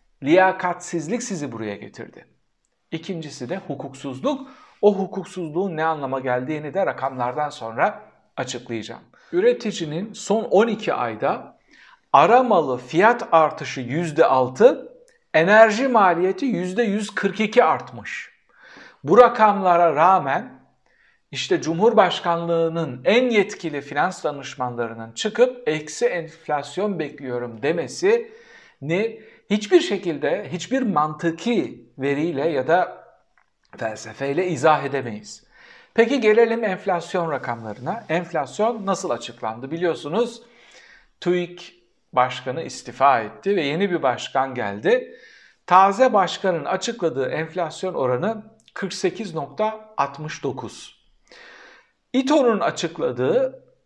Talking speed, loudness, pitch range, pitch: 85 wpm, -21 LUFS, 145-220 Hz, 180 Hz